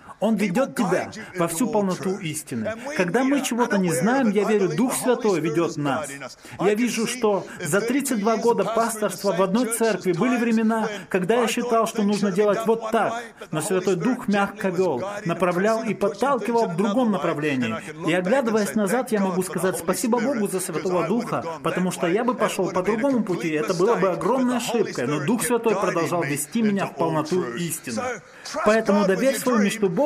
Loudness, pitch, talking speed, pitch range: -23 LUFS, 205 Hz, 175 wpm, 185-230 Hz